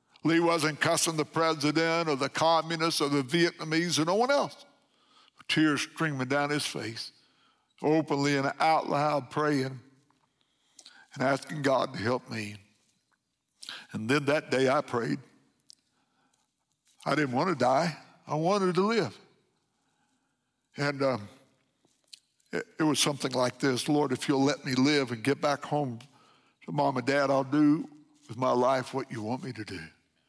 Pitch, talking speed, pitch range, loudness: 145 Hz, 155 wpm, 130-155 Hz, -28 LUFS